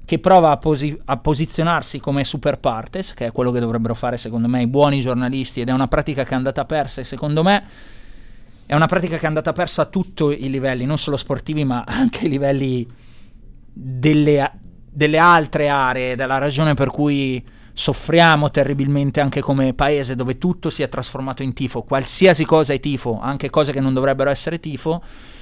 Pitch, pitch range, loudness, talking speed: 140 Hz, 130-155 Hz, -18 LUFS, 190 wpm